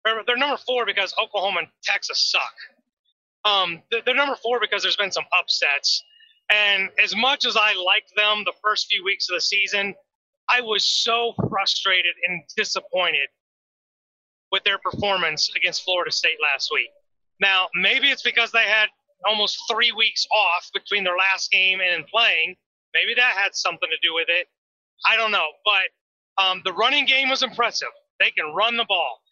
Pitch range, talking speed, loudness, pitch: 190-245 Hz, 170 wpm, -20 LUFS, 205 Hz